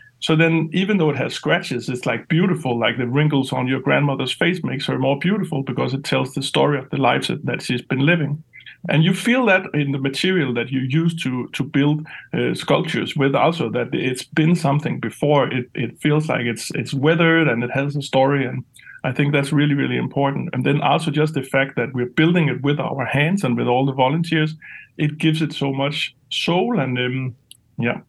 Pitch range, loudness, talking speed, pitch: 130-160 Hz, -20 LUFS, 215 wpm, 140 Hz